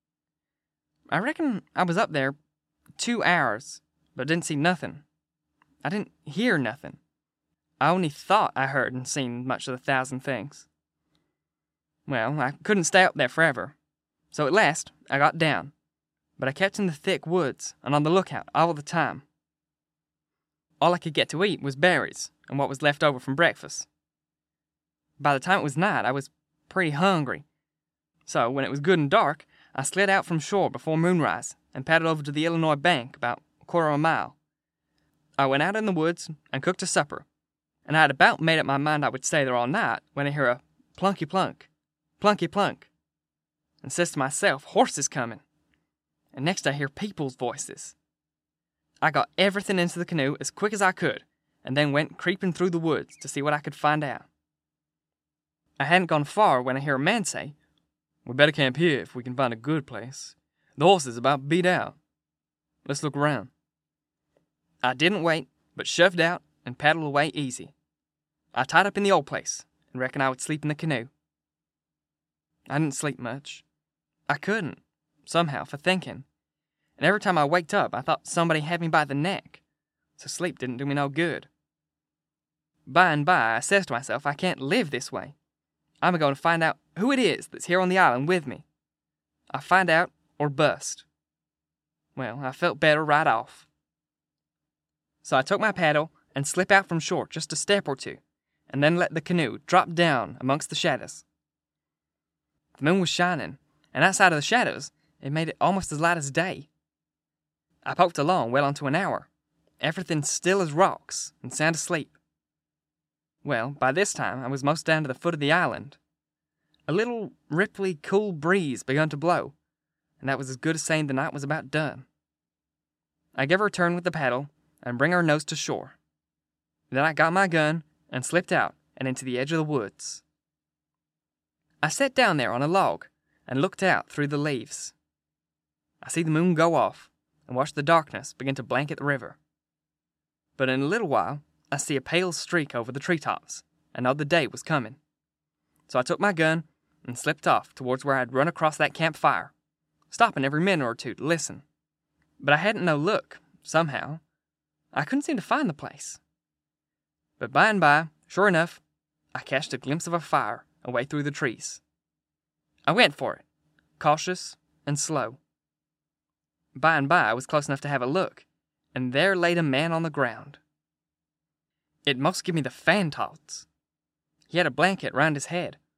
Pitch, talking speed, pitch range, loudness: 150 Hz, 190 wpm, 140-175 Hz, -25 LUFS